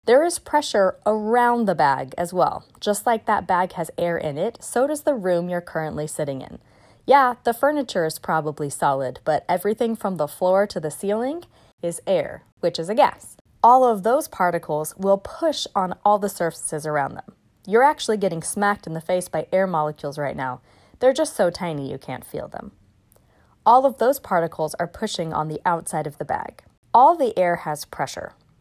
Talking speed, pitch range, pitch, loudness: 195 wpm, 155-225 Hz, 180 Hz, -22 LUFS